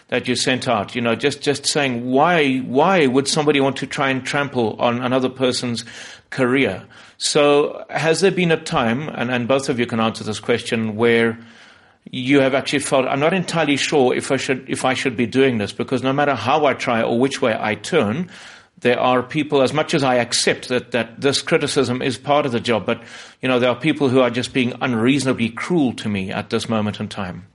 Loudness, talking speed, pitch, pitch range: -19 LUFS, 220 wpm, 130 Hz, 120-140 Hz